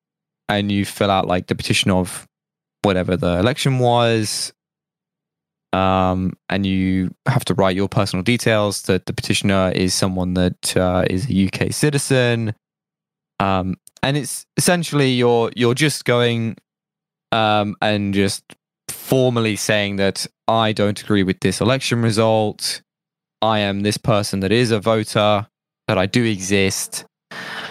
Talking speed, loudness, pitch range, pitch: 140 wpm, -19 LUFS, 95-125 Hz, 110 Hz